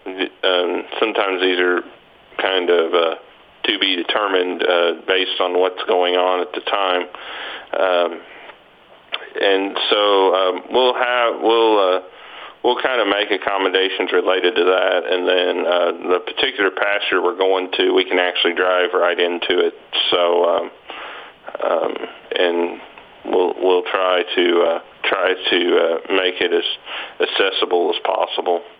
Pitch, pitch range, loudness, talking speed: 95 Hz, 90-125 Hz, -18 LUFS, 145 wpm